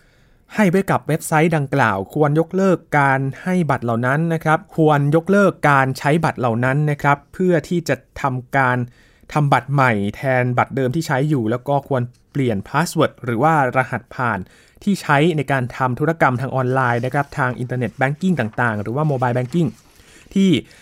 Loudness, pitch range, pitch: -18 LUFS, 125-160 Hz, 140 Hz